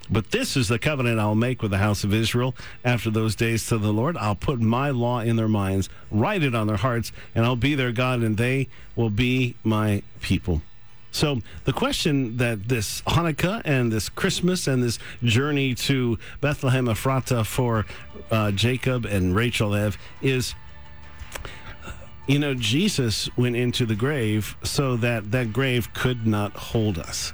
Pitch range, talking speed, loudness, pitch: 105-130 Hz, 170 wpm, -24 LUFS, 120 Hz